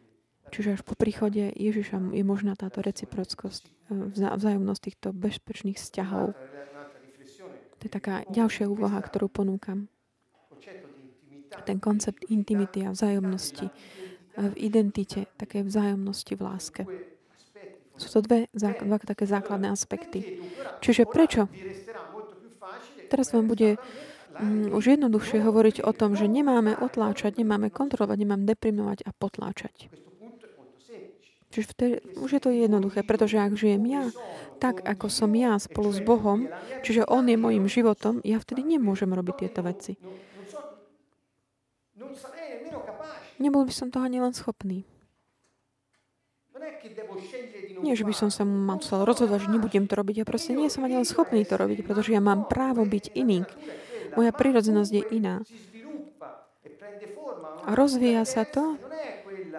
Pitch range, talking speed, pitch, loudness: 195-235 Hz, 130 wpm, 210 Hz, -26 LUFS